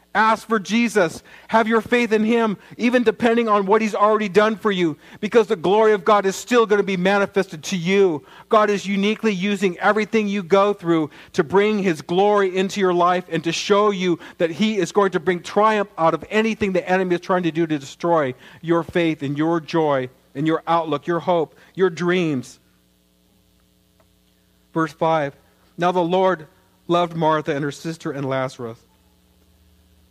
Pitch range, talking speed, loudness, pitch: 160-205 Hz, 180 wpm, -20 LUFS, 180 Hz